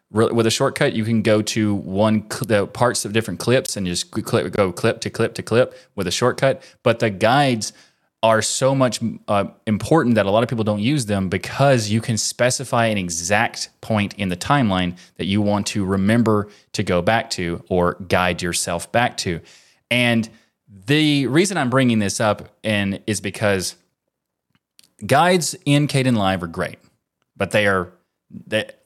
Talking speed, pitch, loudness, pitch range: 180 wpm, 110 Hz, -20 LUFS, 100-120 Hz